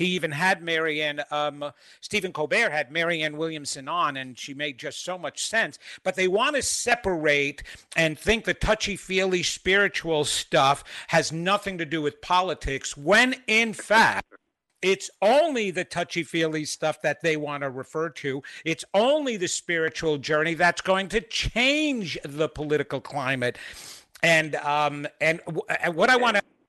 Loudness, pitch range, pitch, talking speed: -24 LUFS, 150-190 Hz, 165 Hz, 160 wpm